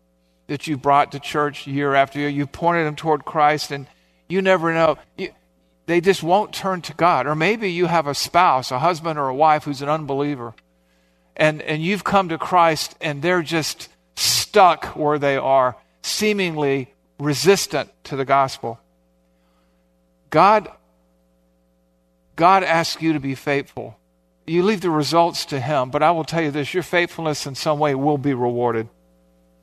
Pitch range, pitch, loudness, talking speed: 110-165 Hz, 145 Hz, -19 LUFS, 170 wpm